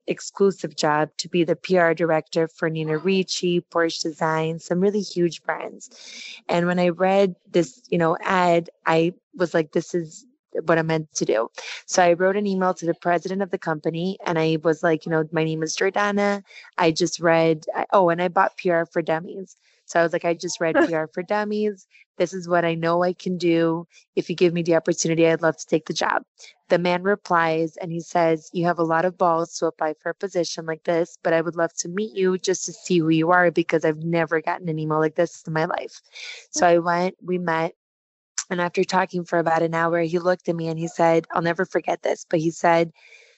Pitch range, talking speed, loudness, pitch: 165-180 Hz, 225 wpm, -22 LUFS, 170 Hz